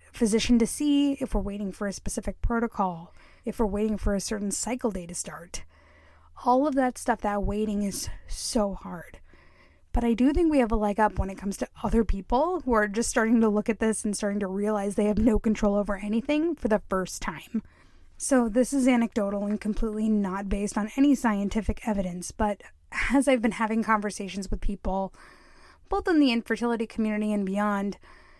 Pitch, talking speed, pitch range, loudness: 215 Hz, 195 wpm, 200-235 Hz, -27 LUFS